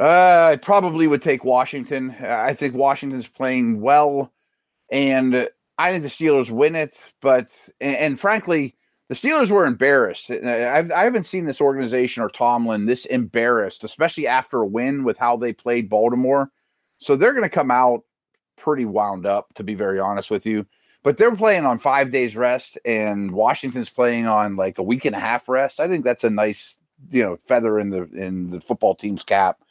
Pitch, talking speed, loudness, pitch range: 125 Hz, 185 wpm, -20 LUFS, 115-140 Hz